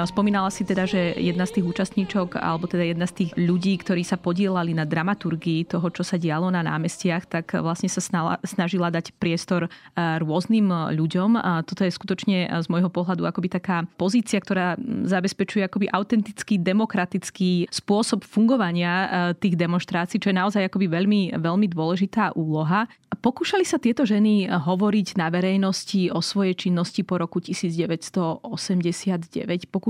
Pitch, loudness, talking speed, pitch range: 185 Hz, -23 LUFS, 150 wpm, 175-200 Hz